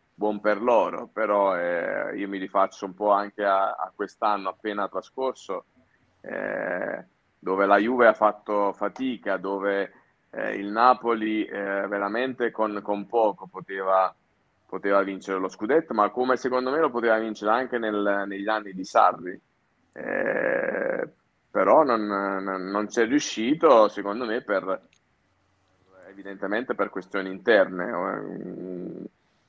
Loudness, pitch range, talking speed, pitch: -25 LUFS, 95-110 Hz, 130 wpm, 100 Hz